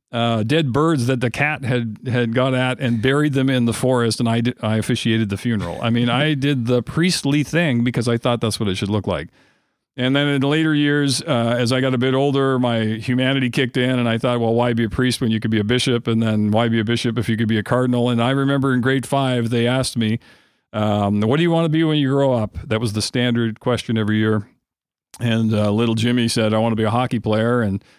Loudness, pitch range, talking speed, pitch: -19 LUFS, 115-130 Hz, 260 wpm, 120 Hz